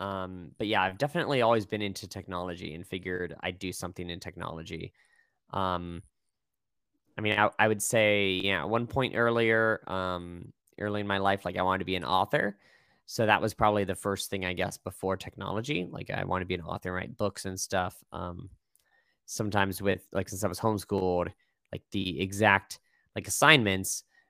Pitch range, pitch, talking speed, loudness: 90-105 Hz, 95 Hz, 190 wpm, -29 LUFS